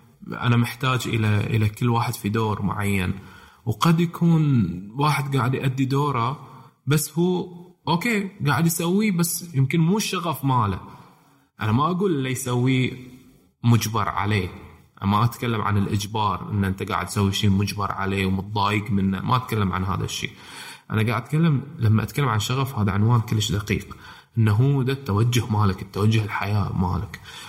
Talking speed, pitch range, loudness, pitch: 155 wpm, 100-135 Hz, -23 LUFS, 115 Hz